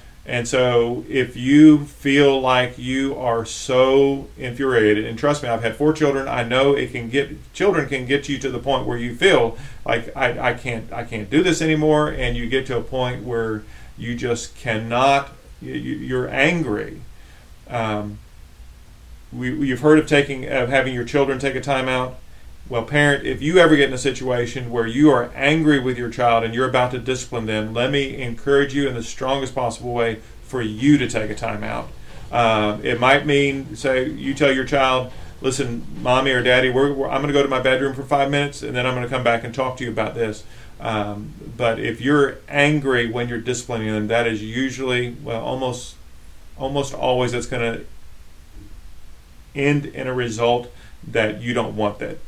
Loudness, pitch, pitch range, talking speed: -20 LUFS, 125 Hz, 115-140 Hz, 195 wpm